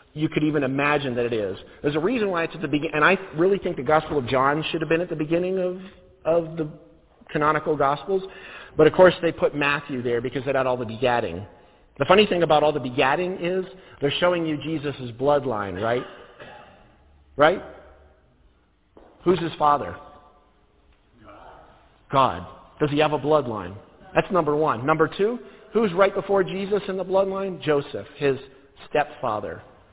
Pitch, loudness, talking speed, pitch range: 155 Hz, -23 LUFS, 170 wpm, 140-180 Hz